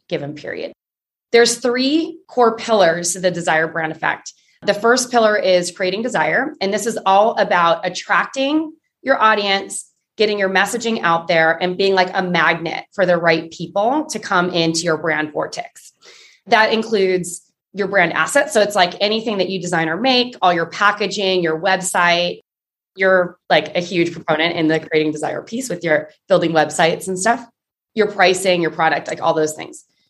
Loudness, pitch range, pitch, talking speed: -17 LUFS, 165-220 Hz, 185 Hz, 175 wpm